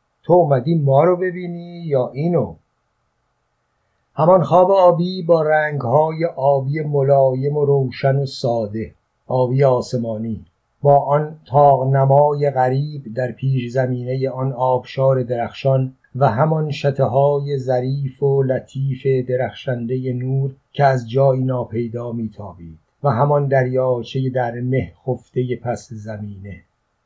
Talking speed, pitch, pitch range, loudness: 115 wpm, 135 Hz, 125-145 Hz, -18 LUFS